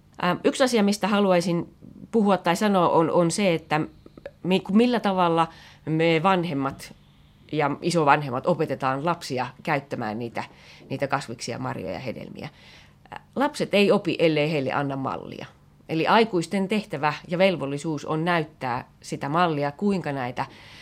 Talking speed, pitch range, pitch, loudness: 125 wpm, 140-190 Hz, 165 Hz, -24 LUFS